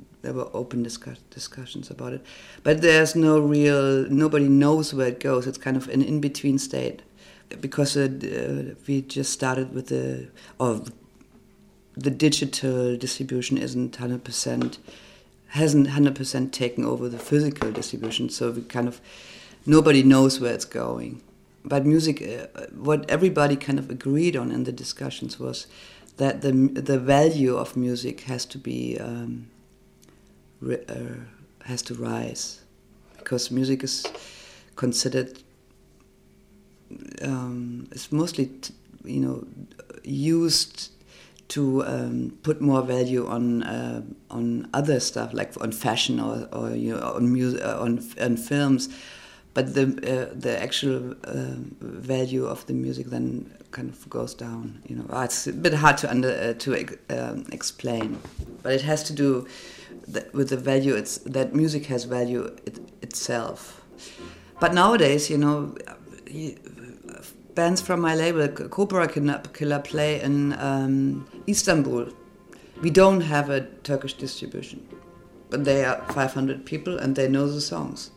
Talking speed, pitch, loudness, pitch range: 140 wpm, 135 Hz, -24 LUFS, 125-145 Hz